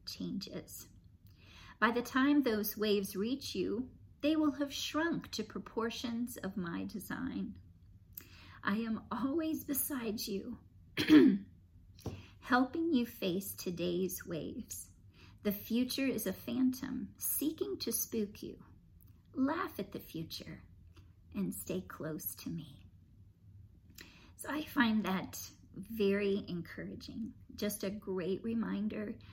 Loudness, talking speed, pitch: -36 LUFS, 115 wpm, 200 Hz